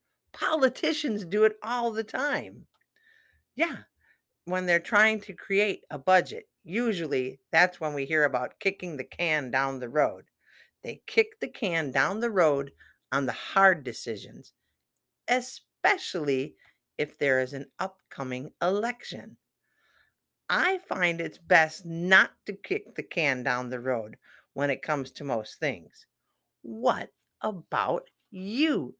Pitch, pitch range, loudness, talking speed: 185 Hz, 145-230 Hz, -27 LUFS, 135 wpm